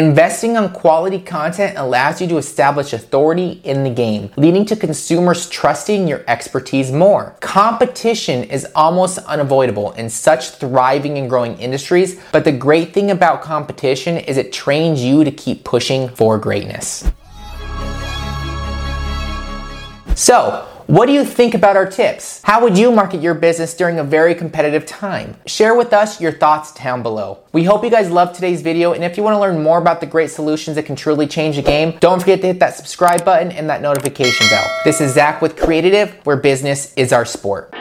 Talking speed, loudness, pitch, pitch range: 185 wpm, -15 LUFS, 155 Hz, 130-180 Hz